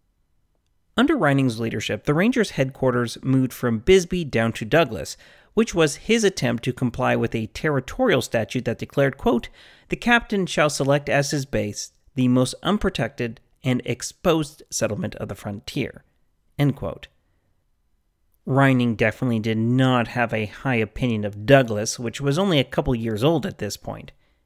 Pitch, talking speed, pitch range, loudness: 125 Hz, 155 wpm, 115-145 Hz, -22 LUFS